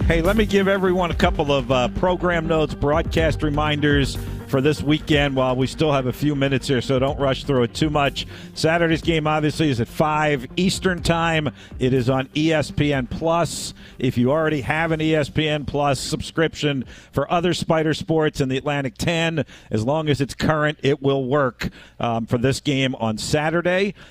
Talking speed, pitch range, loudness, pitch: 185 wpm, 135-160 Hz, -21 LUFS, 150 Hz